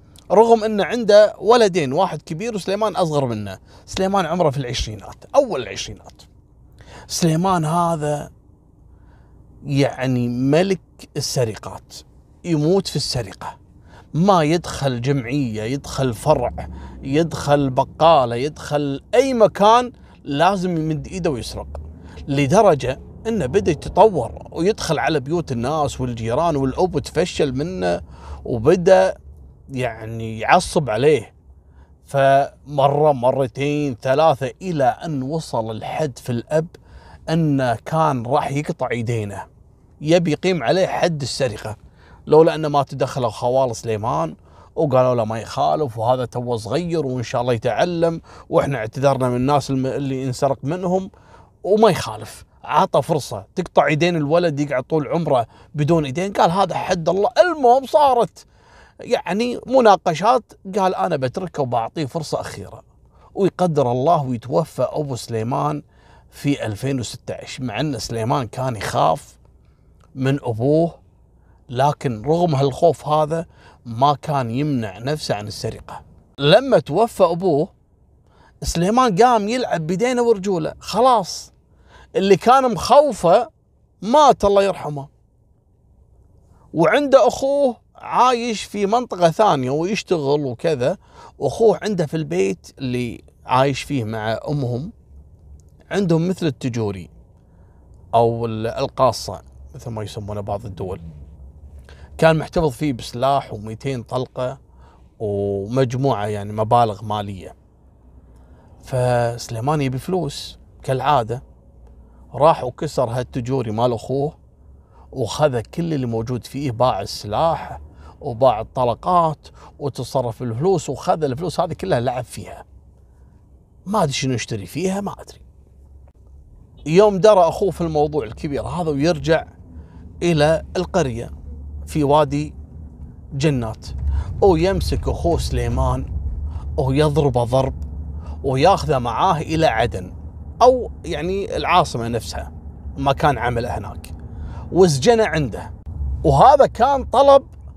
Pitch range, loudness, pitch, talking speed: 105-165 Hz, -19 LUFS, 135 Hz, 110 wpm